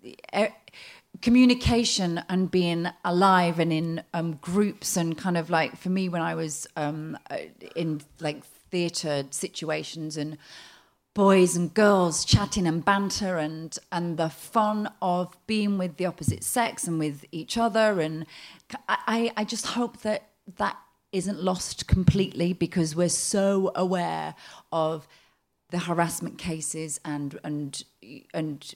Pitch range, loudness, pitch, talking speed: 160-195 Hz, -26 LUFS, 175 Hz, 135 wpm